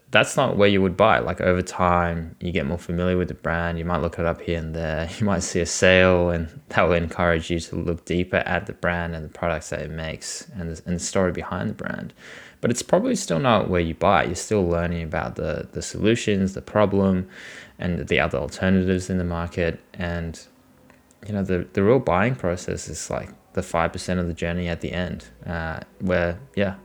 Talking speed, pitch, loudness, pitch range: 215 wpm, 85 Hz, -23 LUFS, 85-95 Hz